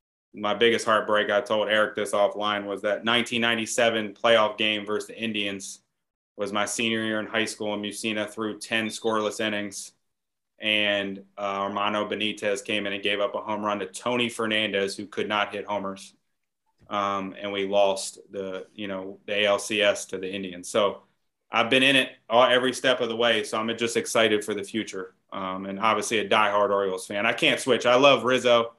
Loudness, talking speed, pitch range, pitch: -24 LUFS, 195 wpm, 100-110 Hz, 105 Hz